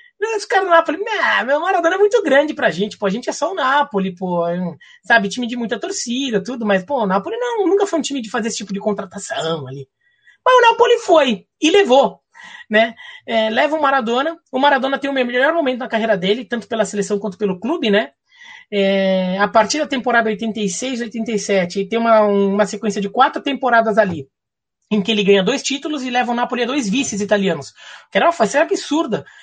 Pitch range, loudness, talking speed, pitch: 205-295 Hz, -17 LUFS, 205 wpm, 240 Hz